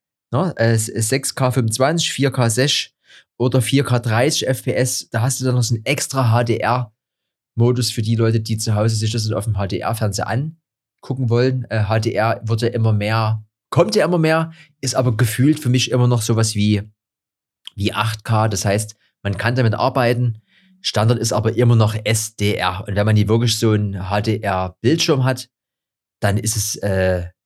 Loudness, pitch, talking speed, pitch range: -18 LUFS, 115 Hz, 180 wpm, 105-130 Hz